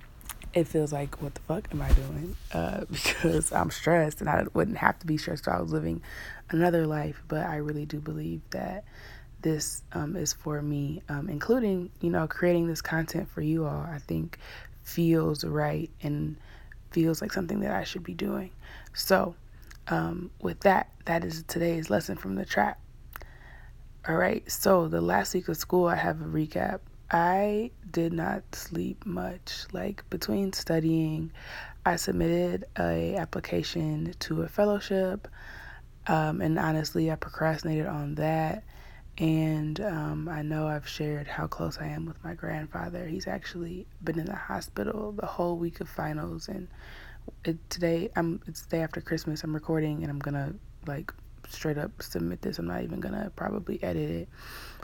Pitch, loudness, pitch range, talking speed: 160 Hz, -30 LUFS, 150-170 Hz, 170 wpm